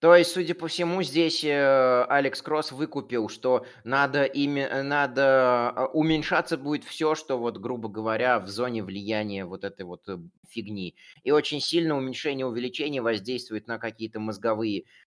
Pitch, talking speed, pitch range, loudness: 130 Hz, 145 wpm, 115-150 Hz, -26 LUFS